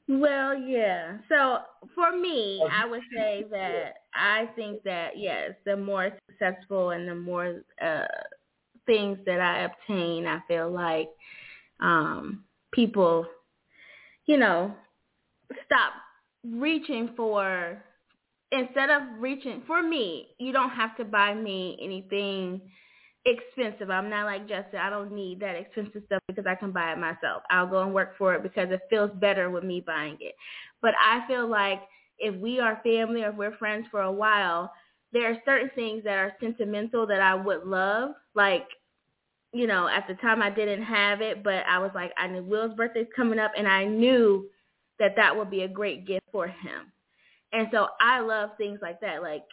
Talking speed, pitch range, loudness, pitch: 175 wpm, 190-230 Hz, -27 LUFS, 205 Hz